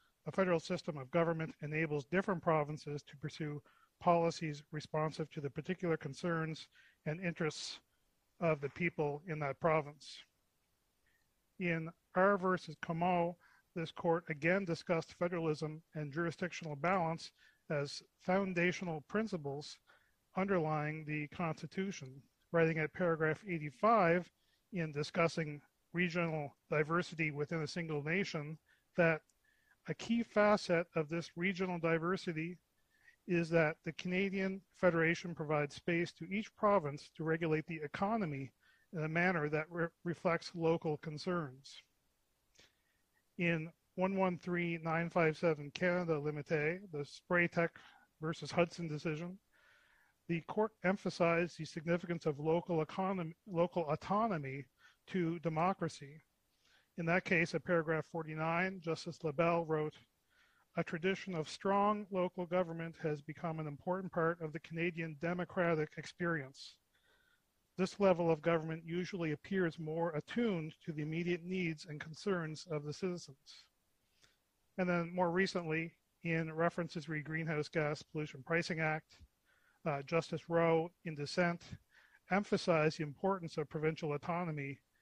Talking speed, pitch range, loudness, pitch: 120 wpm, 155-180 Hz, -37 LUFS, 165 Hz